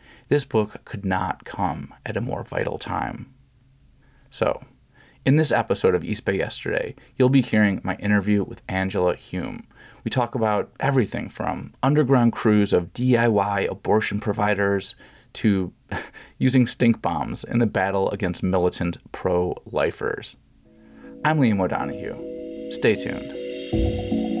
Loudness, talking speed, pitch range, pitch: -23 LUFS, 130 wpm, 100-130 Hz, 110 Hz